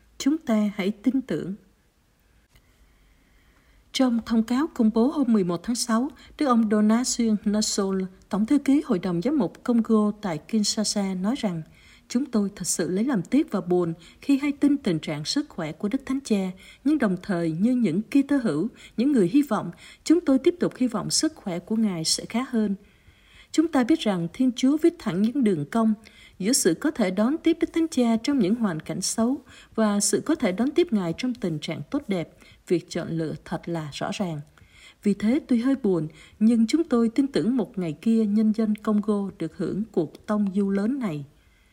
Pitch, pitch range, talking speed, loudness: 215 Hz, 185-255 Hz, 205 wpm, -24 LUFS